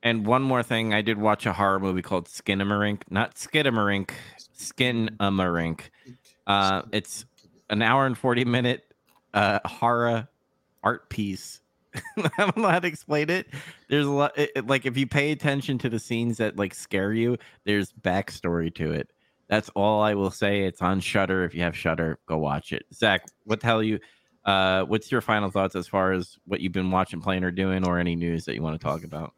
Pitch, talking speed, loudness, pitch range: 105 Hz, 200 wpm, -25 LUFS, 95-125 Hz